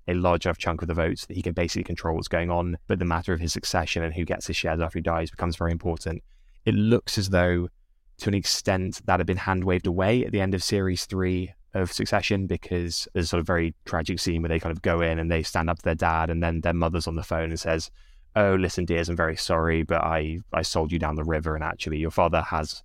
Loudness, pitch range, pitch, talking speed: -26 LUFS, 80-90 Hz, 85 Hz, 270 wpm